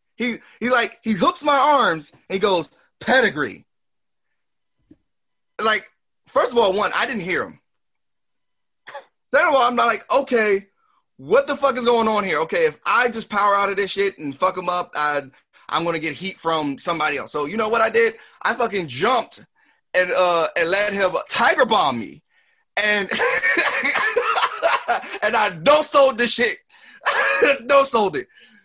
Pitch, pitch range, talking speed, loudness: 220 Hz, 185-275 Hz, 170 wpm, -19 LUFS